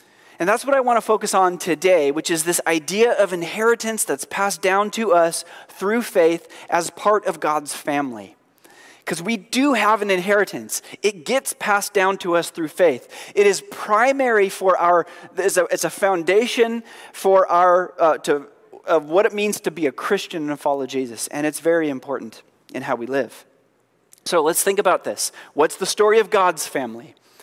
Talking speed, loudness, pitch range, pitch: 190 wpm, -20 LUFS, 170-220 Hz, 195 Hz